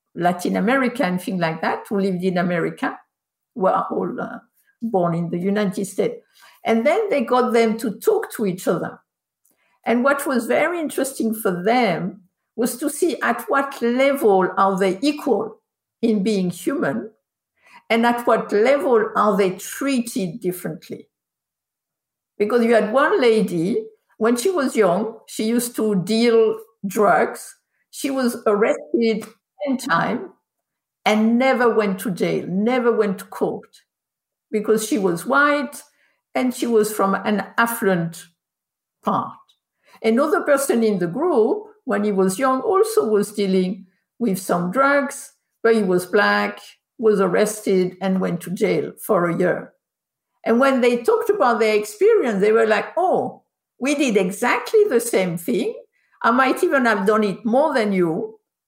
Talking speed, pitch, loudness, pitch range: 150 wpm, 225 Hz, -20 LUFS, 195-265 Hz